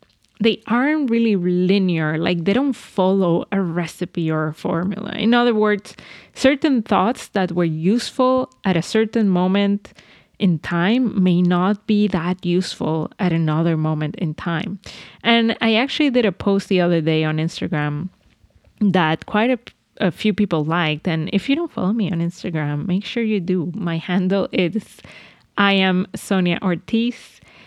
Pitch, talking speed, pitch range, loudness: 190 Hz, 160 wpm, 170-215 Hz, -19 LUFS